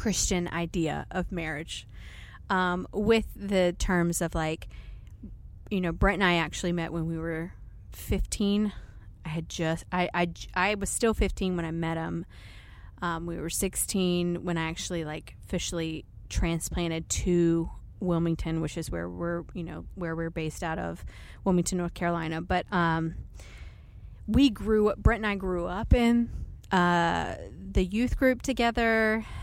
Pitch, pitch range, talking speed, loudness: 170 Hz, 160-185 Hz, 155 wpm, -29 LUFS